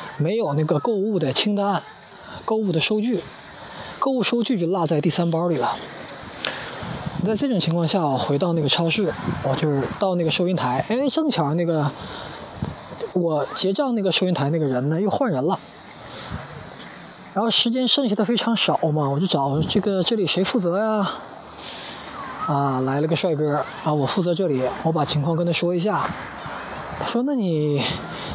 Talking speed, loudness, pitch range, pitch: 245 characters per minute, -22 LUFS, 150-210 Hz, 175 Hz